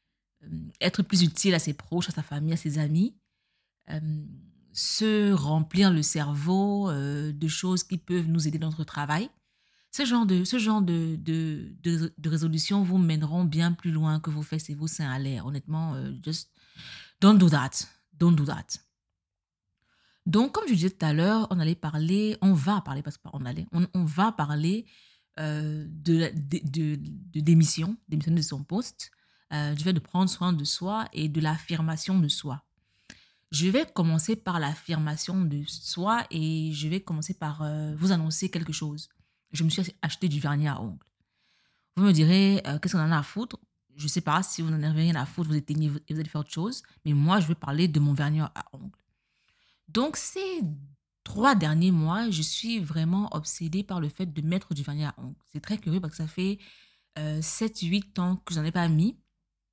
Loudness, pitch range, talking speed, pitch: -27 LUFS, 155-185 Hz, 200 wpm, 165 Hz